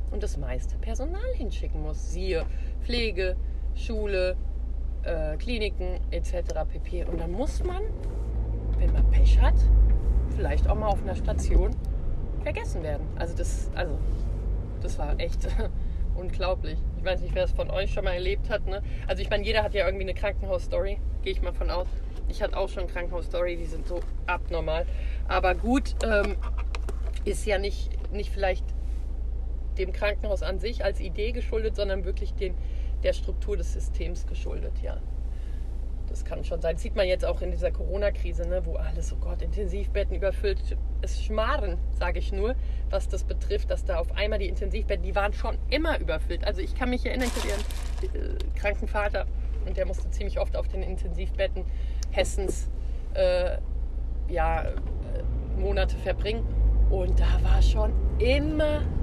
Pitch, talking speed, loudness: 75 Hz, 165 wpm, -29 LUFS